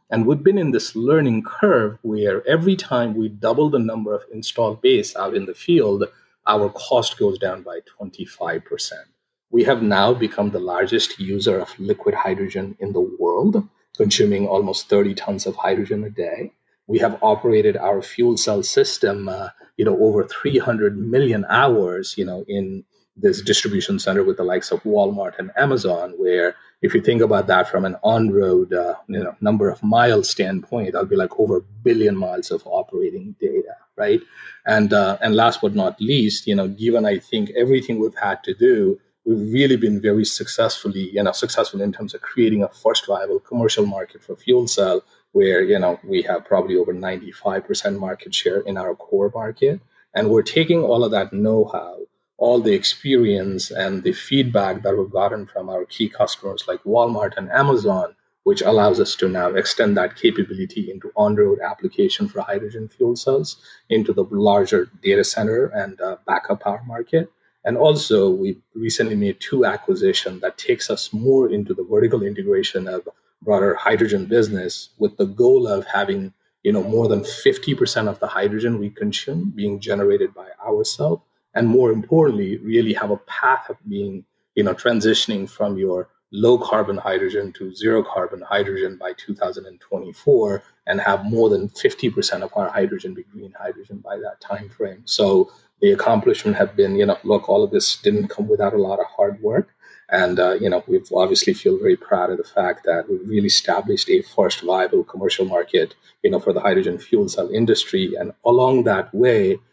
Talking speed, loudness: 180 wpm, -19 LUFS